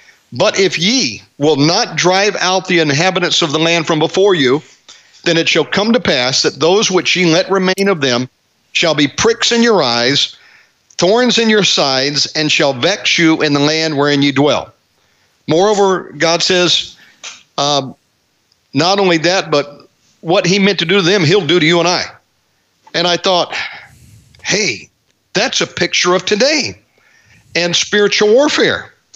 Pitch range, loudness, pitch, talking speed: 145-195 Hz, -12 LUFS, 170 Hz, 170 wpm